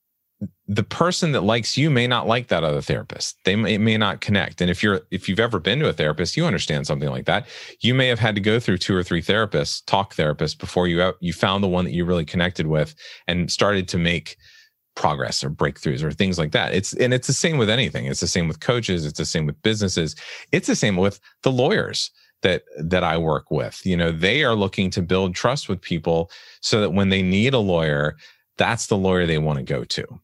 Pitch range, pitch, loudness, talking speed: 85-110 Hz, 95 Hz, -21 LUFS, 235 wpm